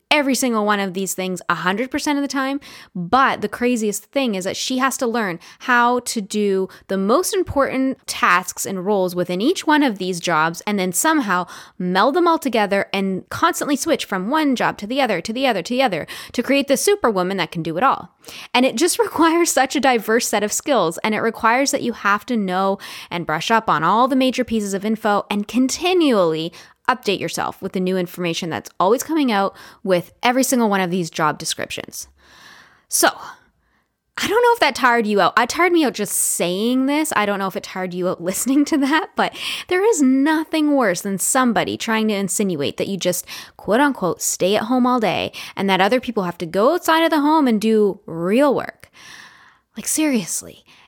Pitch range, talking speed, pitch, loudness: 190-270 Hz, 210 wpm, 225 Hz, -19 LUFS